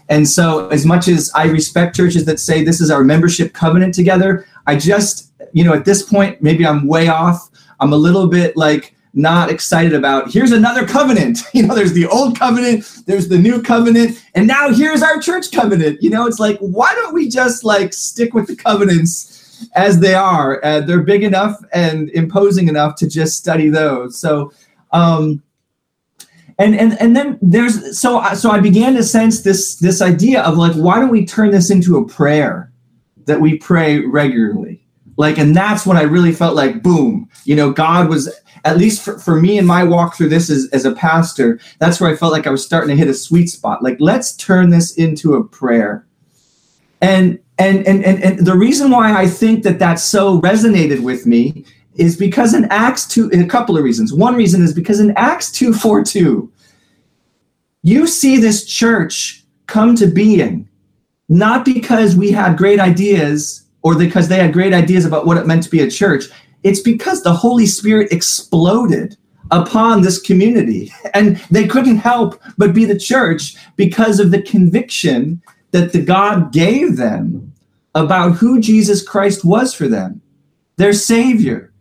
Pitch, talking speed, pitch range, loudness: 185 Hz, 185 wpm, 160-215 Hz, -12 LUFS